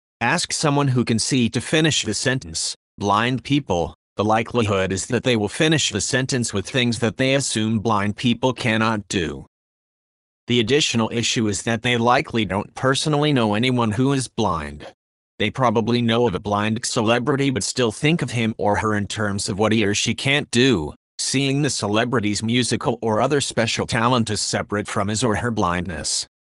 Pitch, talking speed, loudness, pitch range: 115 Hz, 185 wpm, -20 LUFS, 105-125 Hz